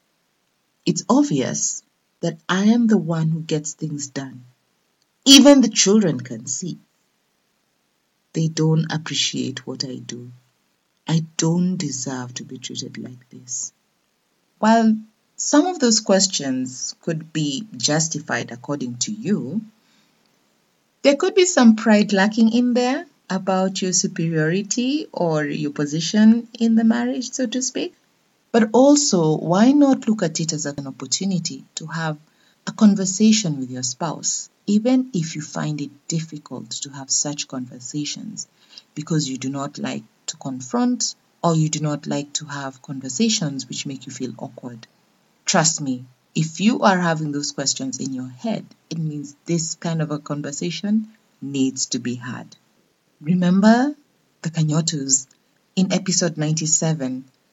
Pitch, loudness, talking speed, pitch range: 165 Hz, -20 LUFS, 140 wpm, 140-215 Hz